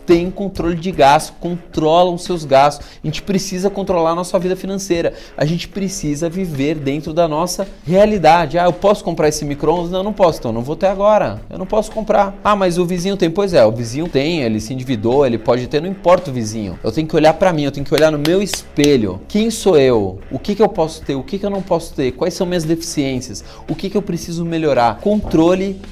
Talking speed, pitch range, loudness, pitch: 240 wpm, 150-195 Hz, -16 LUFS, 175 Hz